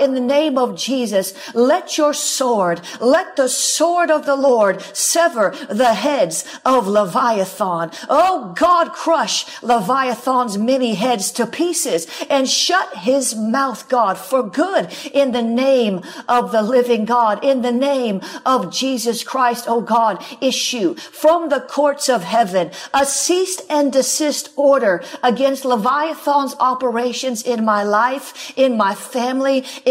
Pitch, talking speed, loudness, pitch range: 260 Hz, 140 wpm, -17 LUFS, 235-290 Hz